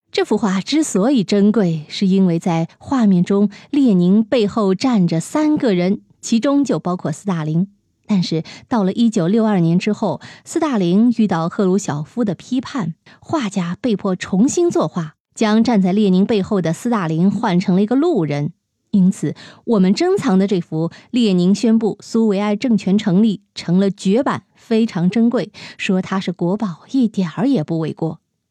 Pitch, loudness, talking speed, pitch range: 200 Hz, -17 LUFS, 245 characters per minute, 180-230 Hz